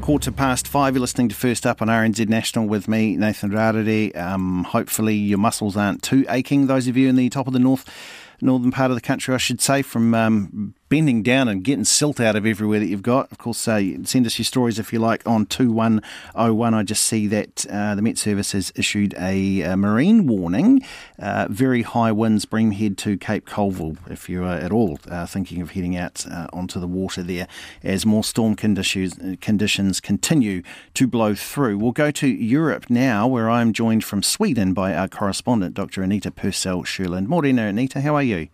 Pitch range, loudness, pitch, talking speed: 95-125 Hz, -20 LUFS, 110 Hz, 205 wpm